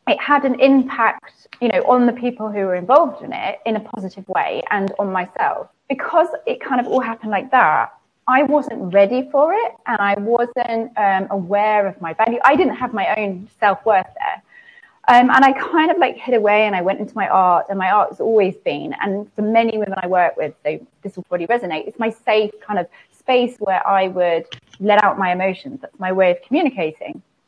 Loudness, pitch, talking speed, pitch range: -18 LUFS, 215 Hz, 215 wpm, 195-255 Hz